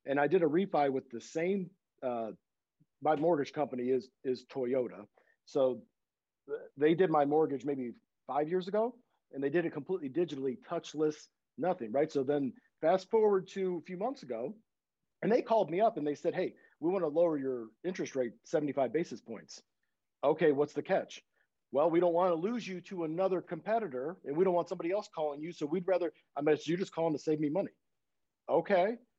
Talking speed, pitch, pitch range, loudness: 200 wpm, 160 Hz, 140-185 Hz, -33 LUFS